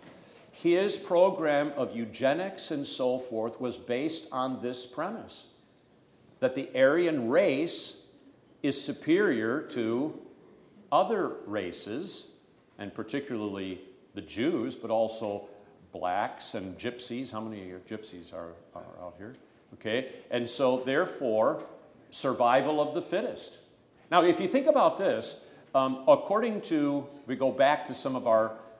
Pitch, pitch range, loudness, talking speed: 125 Hz, 110-150 Hz, -29 LUFS, 130 wpm